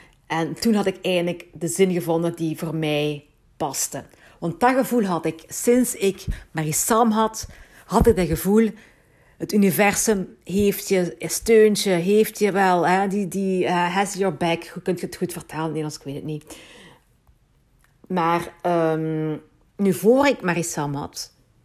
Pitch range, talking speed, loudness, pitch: 160-200 Hz, 165 wpm, -22 LUFS, 175 Hz